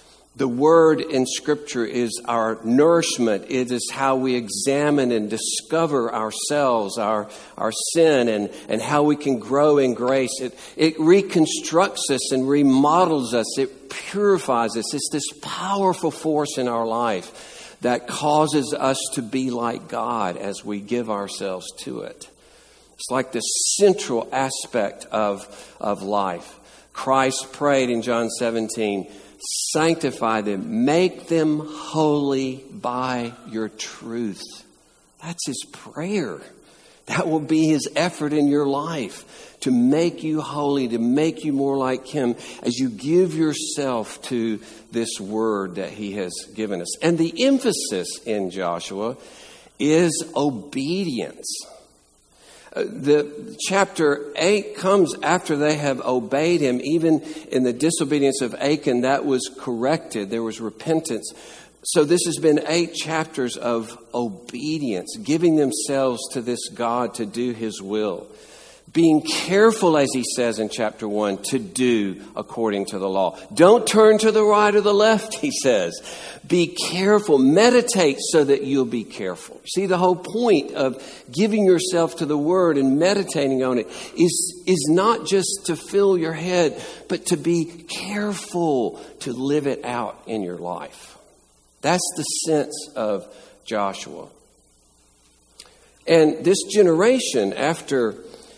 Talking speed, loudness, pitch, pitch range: 140 wpm, -21 LUFS, 140 Hz, 120-165 Hz